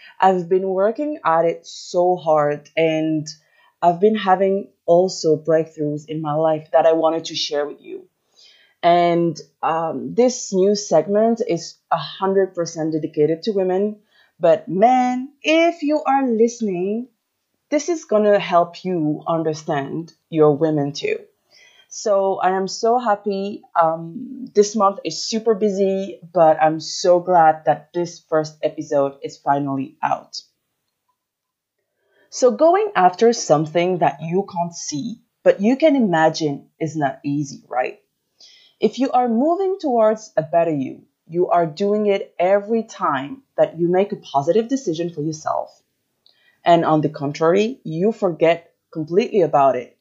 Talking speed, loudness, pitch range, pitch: 140 wpm, -19 LUFS, 160-220 Hz, 180 Hz